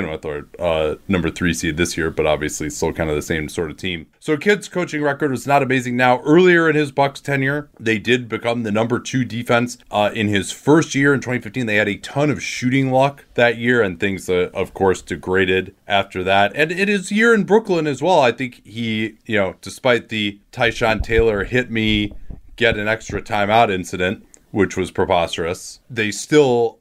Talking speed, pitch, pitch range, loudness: 205 wpm, 115 Hz, 100-140 Hz, -18 LUFS